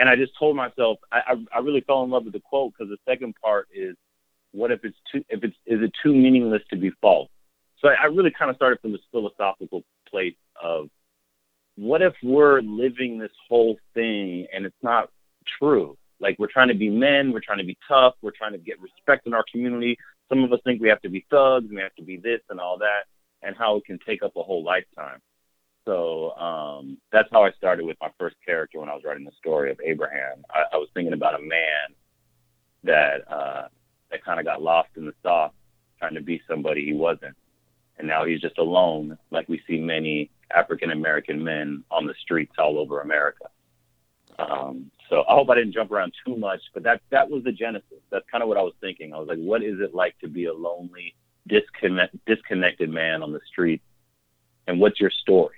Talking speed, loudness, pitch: 220 wpm, -23 LUFS, 105 Hz